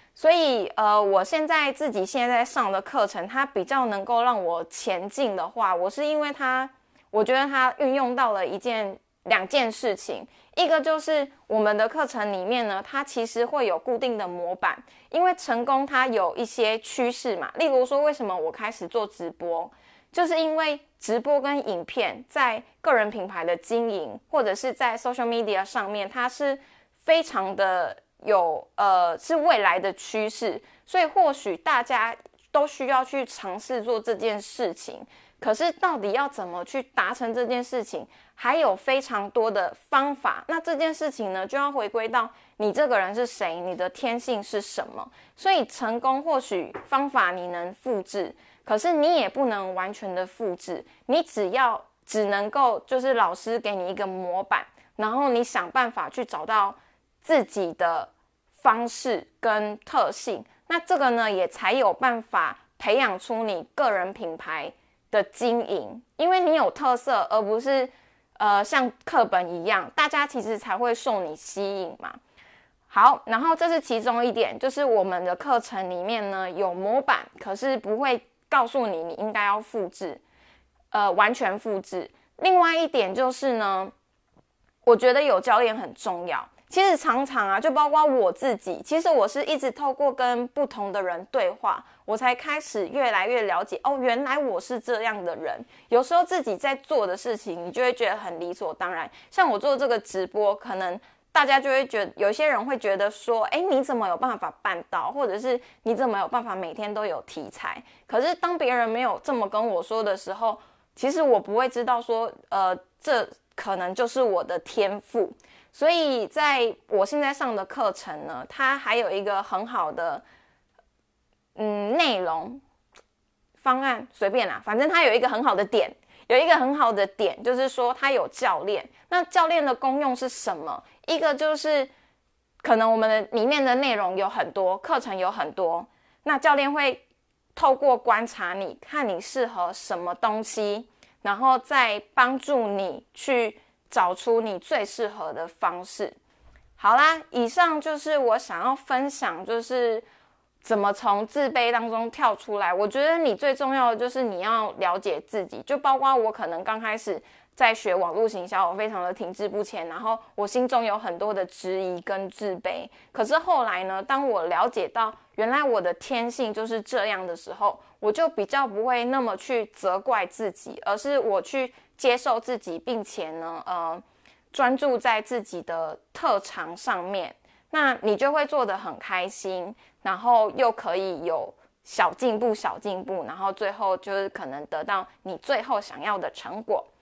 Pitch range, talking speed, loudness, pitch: 200-270 Hz, 255 characters per minute, -25 LUFS, 235 Hz